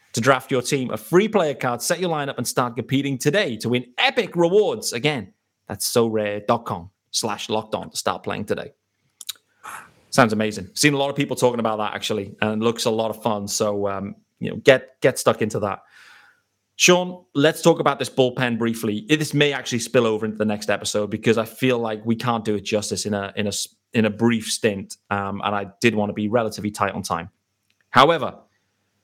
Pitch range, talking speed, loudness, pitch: 105-135 Hz, 215 wpm, -21 LUFS, 115 Hz